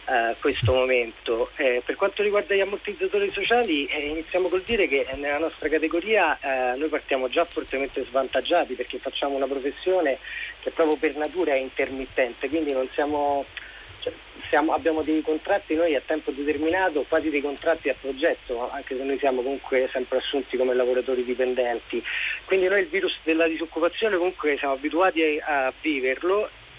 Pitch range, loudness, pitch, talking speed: 135-180 Hz, -25 LUFS, 155 Hz, 165 wpm